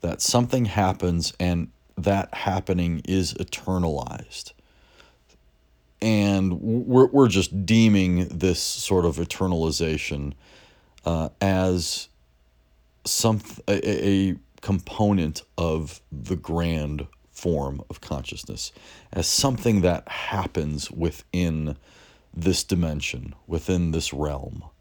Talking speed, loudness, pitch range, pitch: 95 wpm, -24 LUFS, 75-95 Hz, 85 Hz